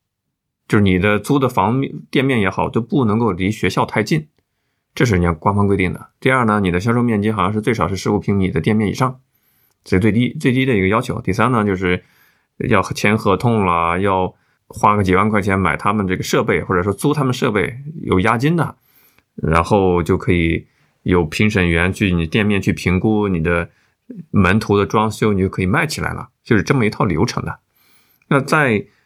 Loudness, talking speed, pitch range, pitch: -17 LUFS, 290 characters per minute, 95-120 Hz, 105 Hz